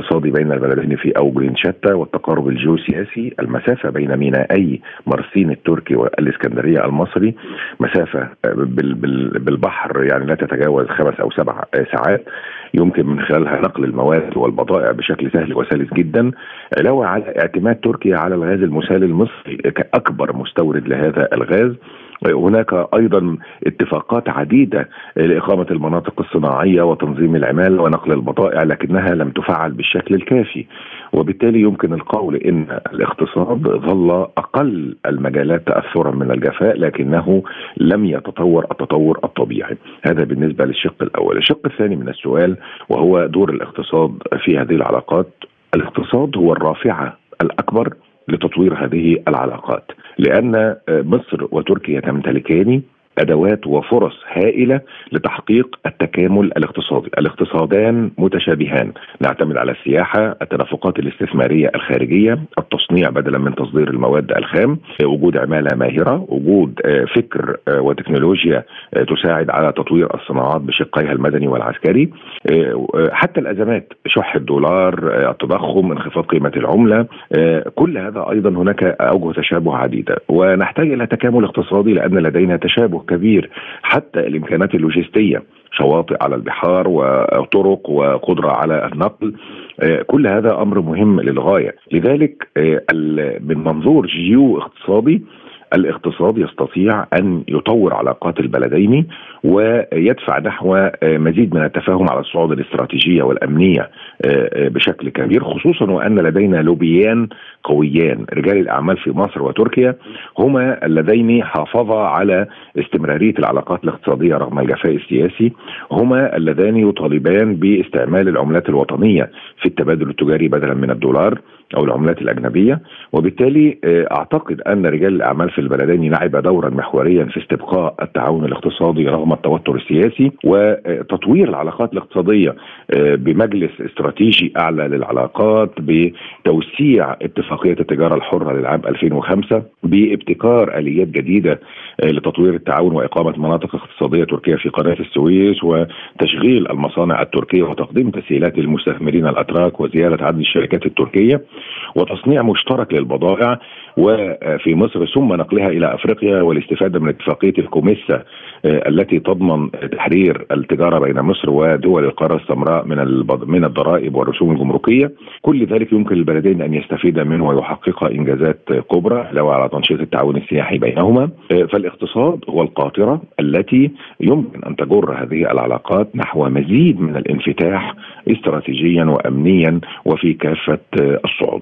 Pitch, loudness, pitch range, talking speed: 85 Hz, -15 LUFS, 75-100 Hz, 115 wpm